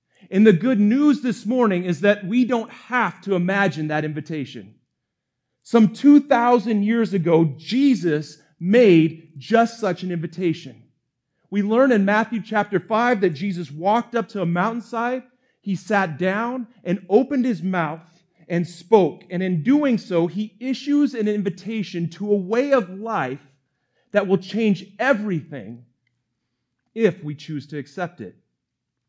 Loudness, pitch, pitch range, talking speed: -20 LUFS, 195 Hz, 165-230 Hz, 145 wpm